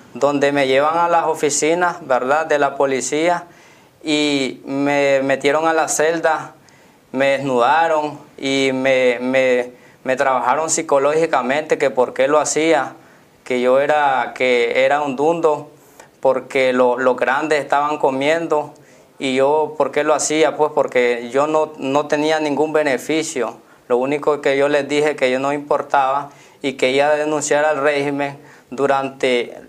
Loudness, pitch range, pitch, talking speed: -17 LUFS, 135-155 Hz, 145 Hz, 150 wpm